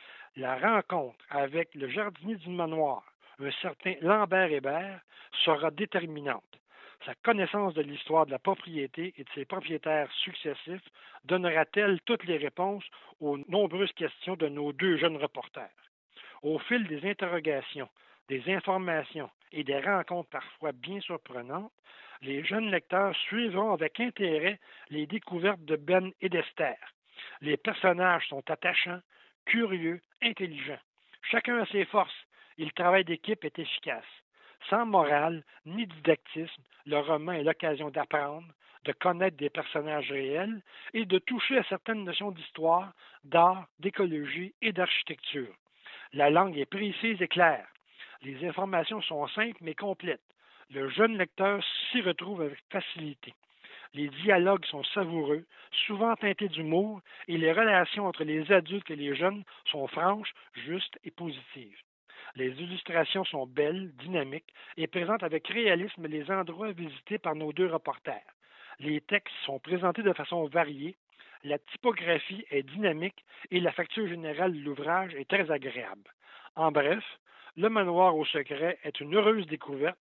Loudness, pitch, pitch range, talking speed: -30 LUFS, 170 Hz, 150-195 Hz, 140 wpm